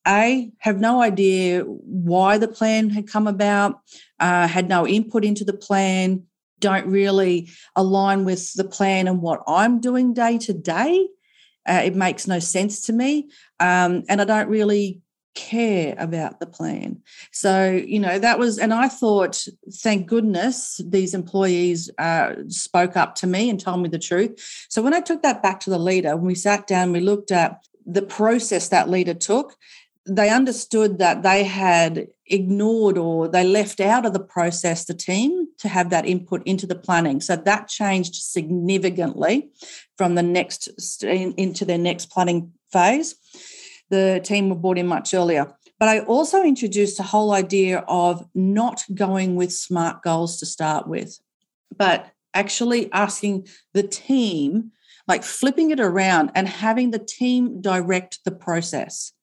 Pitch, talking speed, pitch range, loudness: 195 Hz, 165 wpm, 180-220 Hz, -20 LUFS